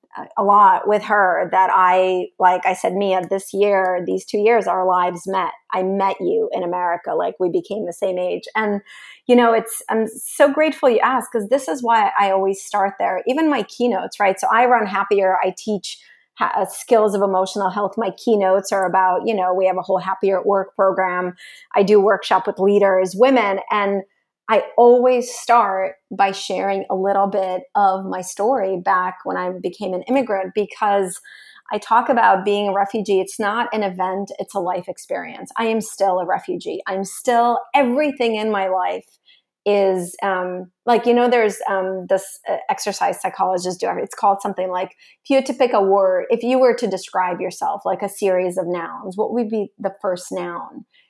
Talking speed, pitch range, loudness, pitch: 195 wpm, 185-230 Hz, -19 LUFS, 195 Hz